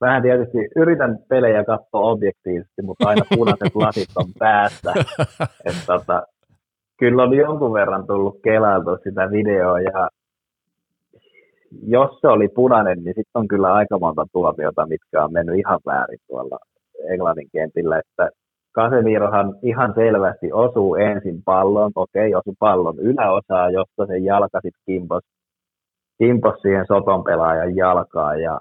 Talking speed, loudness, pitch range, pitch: 130 wpm, -18 LUFS, 95-115 Hz, 100 Hz